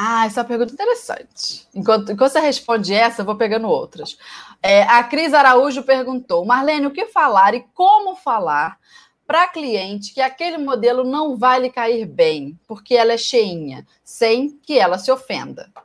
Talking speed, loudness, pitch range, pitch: 175 wpm, -17 LUFS, 225-290 Hz, 250 Hz